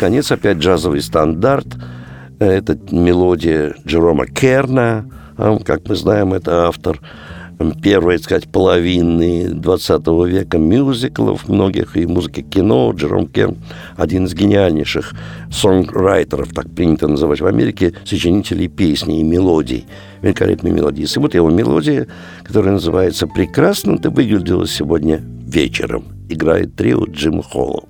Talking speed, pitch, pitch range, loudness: 120 wpm, 85 Hz, 80-100 Hz, -15 LUFS